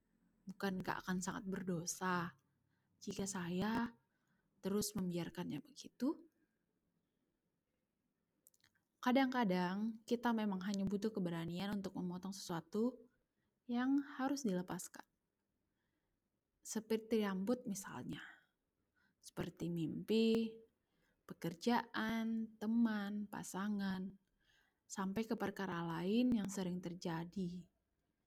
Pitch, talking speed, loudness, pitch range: 200 Hz, 80 wpm, -41 LUFS, 180-225 Hz